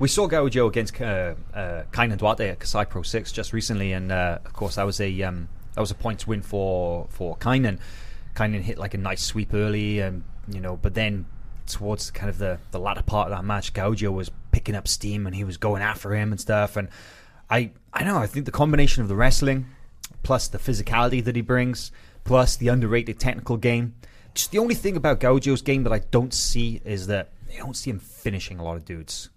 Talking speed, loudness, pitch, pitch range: 225 wpm, -25 LUFS, 105 Hz, 95-120 Hz